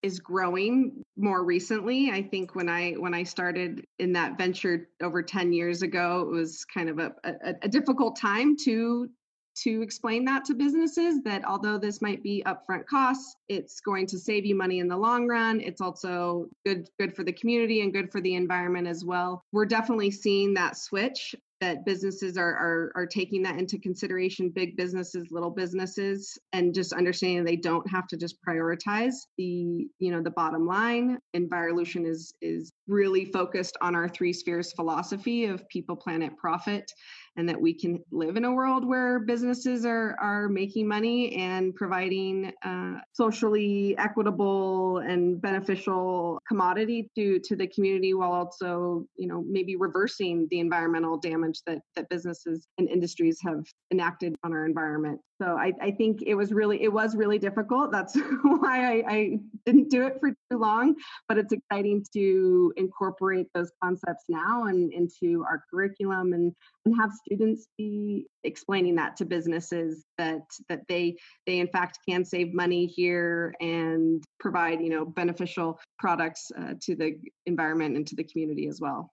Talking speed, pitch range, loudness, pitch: 170 wpm, 175-210 Hz, -28 LUFS, 185 Hz